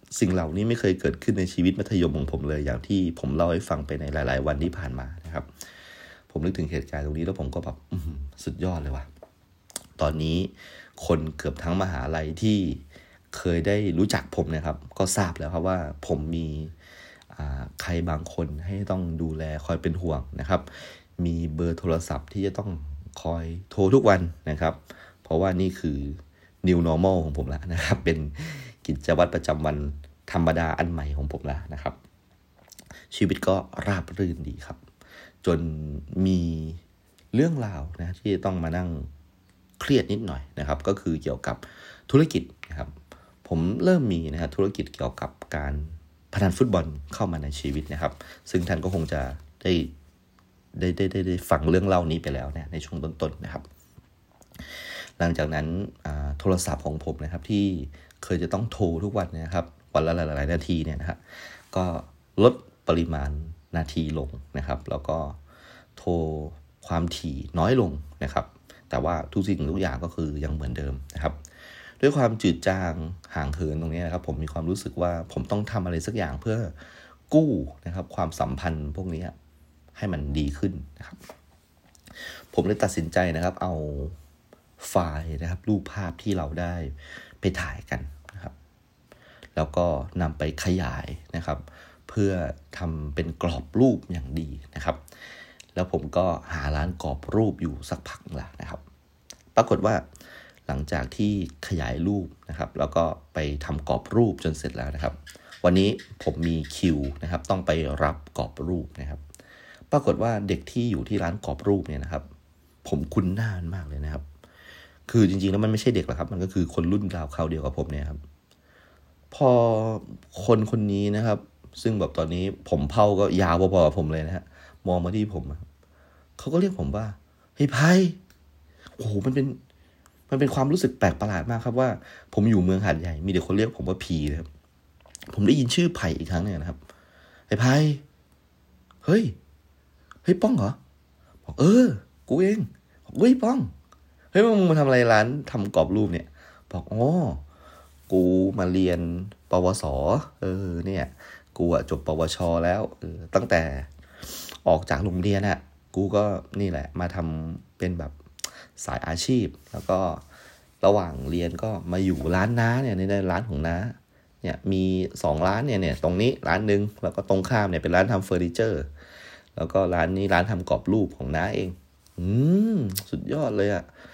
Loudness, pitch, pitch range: -26 LUFS, 85 Hz, 75-95 Hz